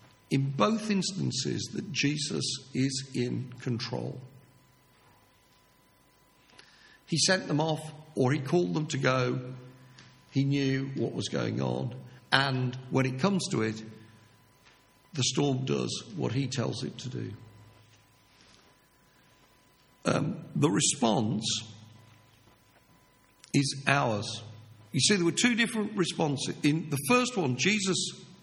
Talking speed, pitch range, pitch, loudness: 120 wpm, 115-155 Hz, 130 Hz, -29 LUFS